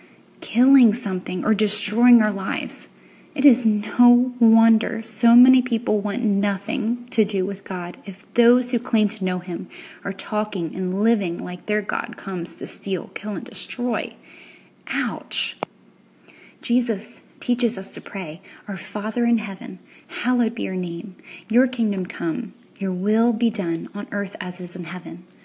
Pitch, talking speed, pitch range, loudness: 215 Hz, 160 wpm, 190-235 Hz, -21 LUFS